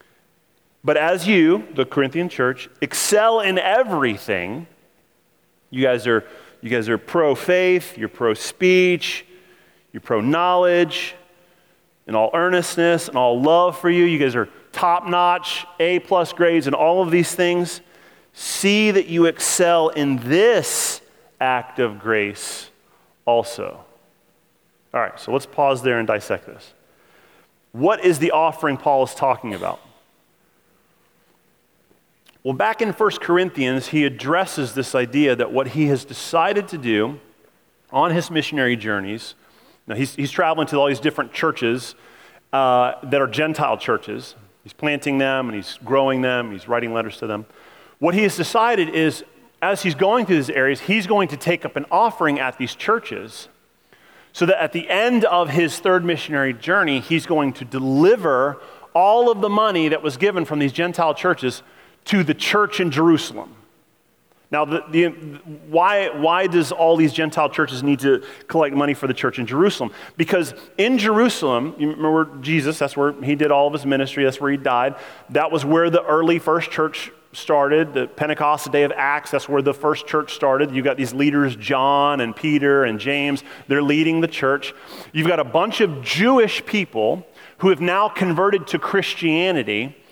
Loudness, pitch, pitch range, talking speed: -19 LUFS, 155 Hz, 135-175 Hz, 165 wpm